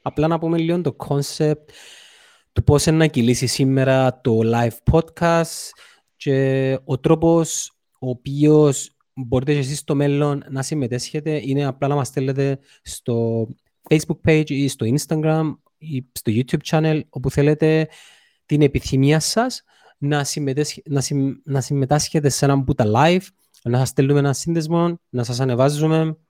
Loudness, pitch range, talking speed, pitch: -19 LUFS, 135-155 Hz, 145 wpm, 145 Hz